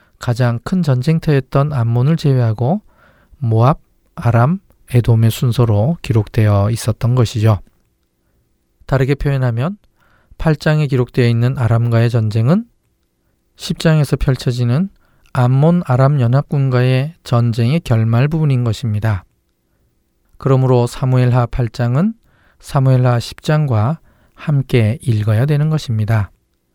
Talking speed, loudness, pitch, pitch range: 250 characters per minute, -15 LUFS, 125 Hz, 115-145 Hz